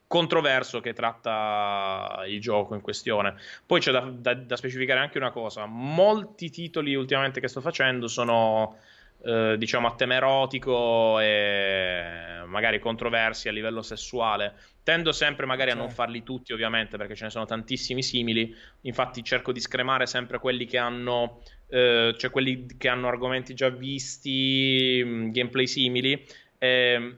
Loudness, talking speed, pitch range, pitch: -26 LUFS, 150 wpm, 115-130 Hz, 125 Hz